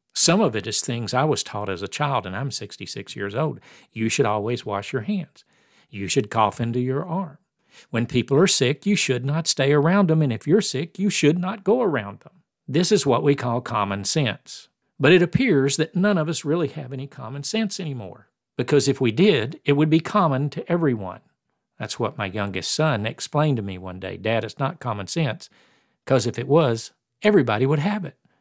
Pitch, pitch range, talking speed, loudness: 140 Hz, 115-165 Hz, 215 wpm, -22 LUFS